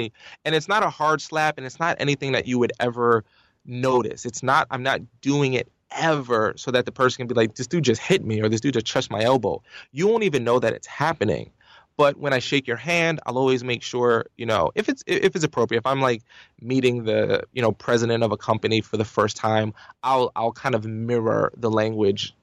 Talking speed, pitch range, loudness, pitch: 235 wpm, 115-140 Hz, -23 LUFS, 125 Hz